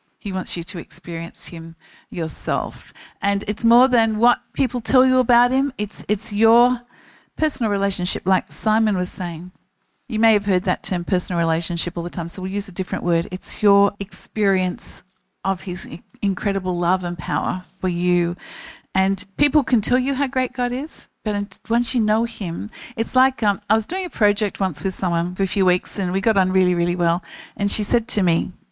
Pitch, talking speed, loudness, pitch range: 200 Hz, 200 wpm, -20 LUFS, 180-230 Hz